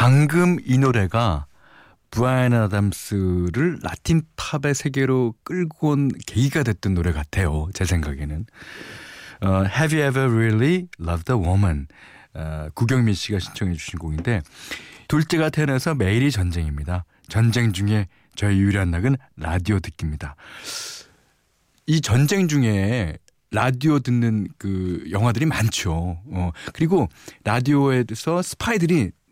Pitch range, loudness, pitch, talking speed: 90-135 Hz, -22 LUFS, 110 Hz, 300 characters per minute